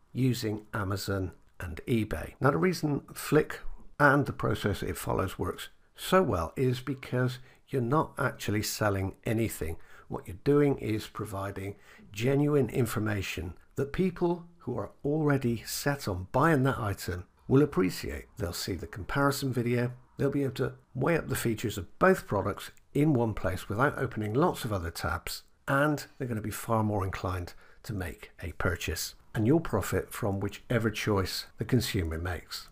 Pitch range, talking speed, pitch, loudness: 100-140 Hz, 160 wpm, 120 Hz, -30 LUFS